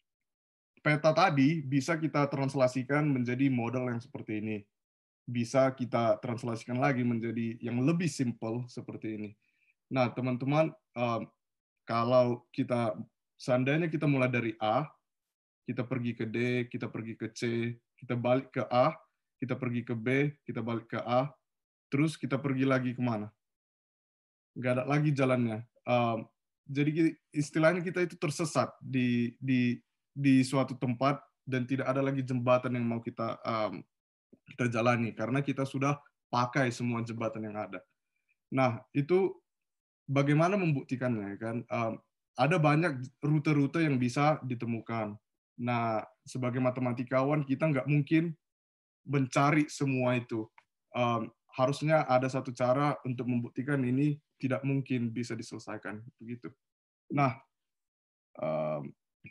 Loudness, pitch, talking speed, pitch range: -31 LUFS, 125 Hz, 125 wpm, 115-140 Hz